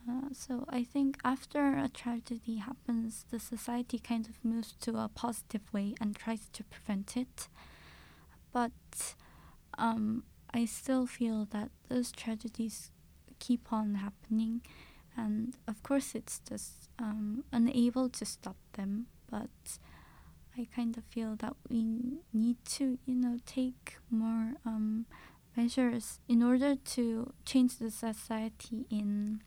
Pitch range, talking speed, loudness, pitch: 220-250 Hz, 130 wpm, -36 LUFS, 235 Hz